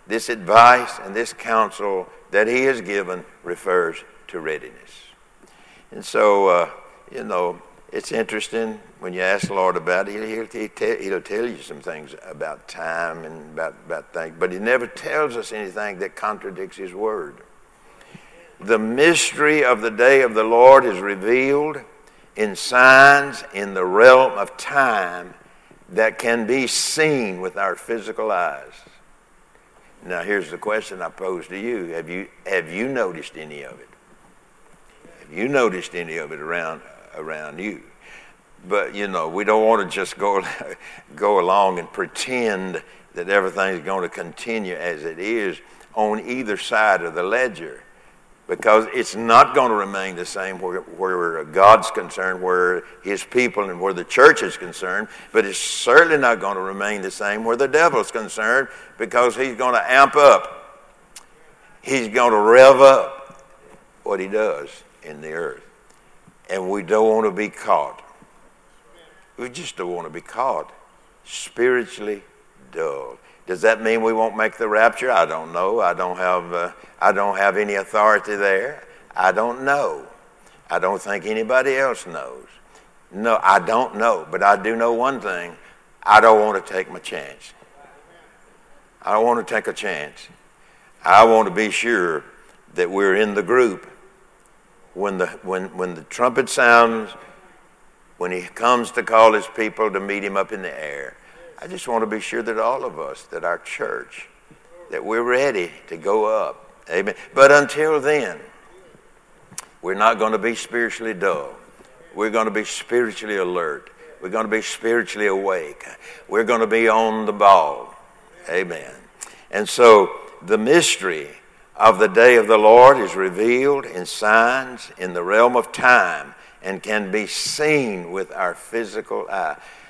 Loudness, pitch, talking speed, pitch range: -18 LUFS, 115 Hz, 165 wpm, 100-140 Hz